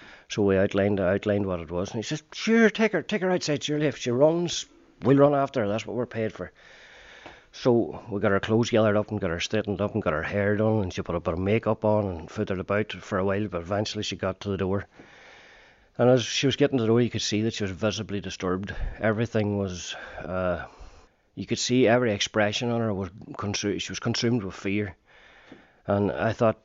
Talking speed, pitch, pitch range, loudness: 230 wpm, 105 Hz, 100-120 Hz, -26 LUFS